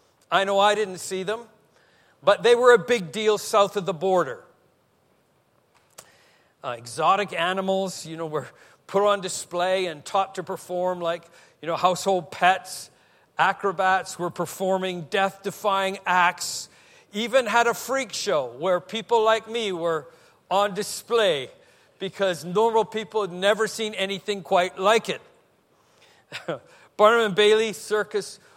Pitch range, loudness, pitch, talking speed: 180-215 Hz, -23 LUFS, 195 Hz, 135 wpm